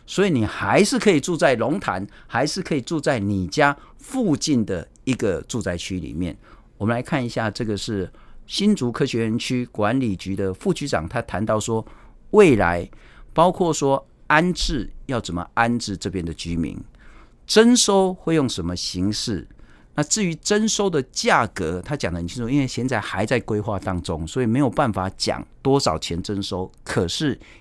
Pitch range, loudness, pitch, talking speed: 95-145 Hz, -22 LUFS, 115 Hz, 255 characters per minute